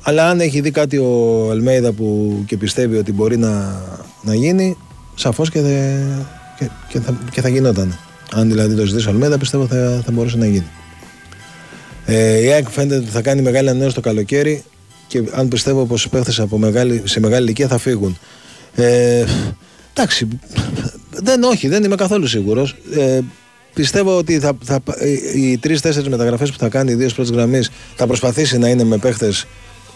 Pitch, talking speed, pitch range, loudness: 125 Hz, 155 wpm, 110-140 Hz, -16 LUFS